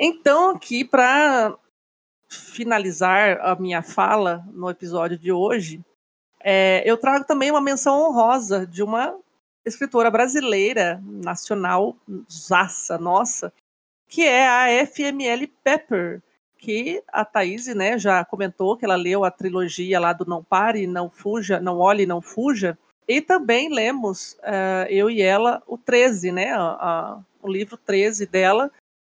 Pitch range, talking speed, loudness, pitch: 185-245 Hz, 140 wpm, -20 LUFS, 205 Hz